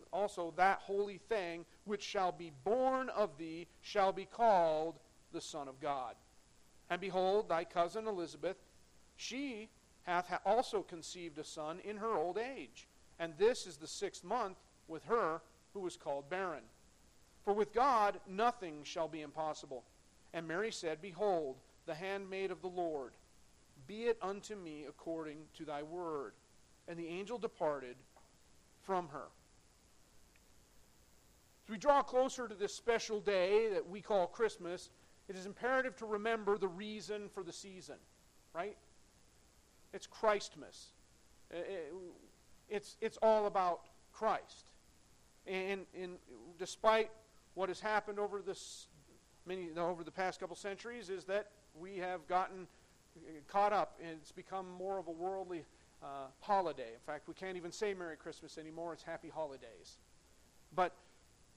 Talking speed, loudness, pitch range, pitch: 145 wpm, -39 LUFS, 165-210 Hz, 185 Hz